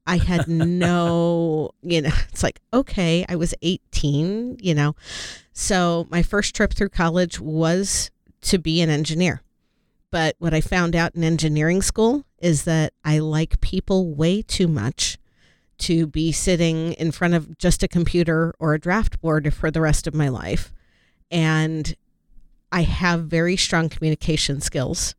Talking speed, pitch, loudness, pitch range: 155 wpm, 165 Hz, -21 LUFS, 155-175 Hz